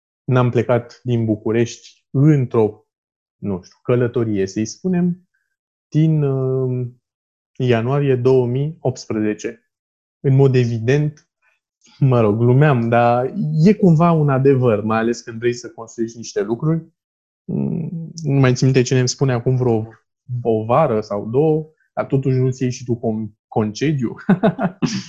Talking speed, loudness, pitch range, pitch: 125 wpm, -18 LUFS, 115-145 Hz, 125 Hz